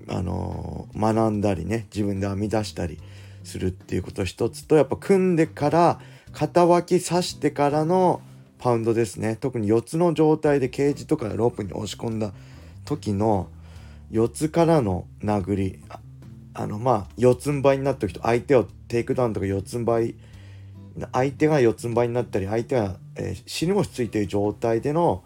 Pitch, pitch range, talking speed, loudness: 115 Hz, 100-140 Hz, 340 characters per minute, -23 LUFS